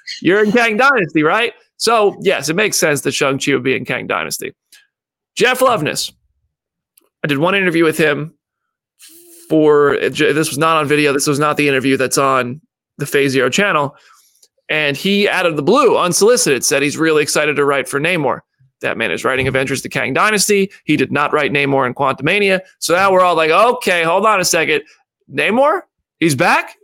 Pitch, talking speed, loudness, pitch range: 155 Hz, 190 wpm, -14 LUFS, 140-205 Hz